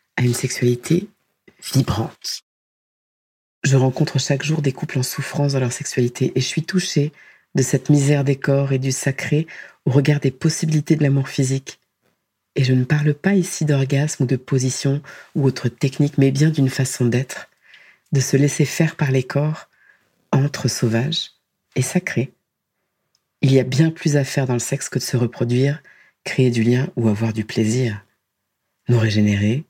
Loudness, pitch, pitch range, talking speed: -20 LUFS, 135 Hz, 125-150 Hz, 175 wpm